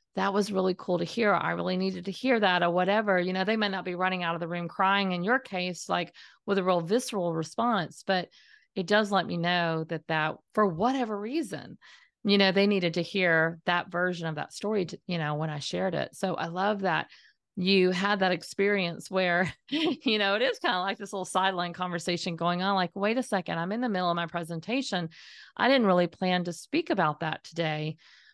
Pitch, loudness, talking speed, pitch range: 185 Hz, -28 LUFS, 225 wpm, 175-205 Hz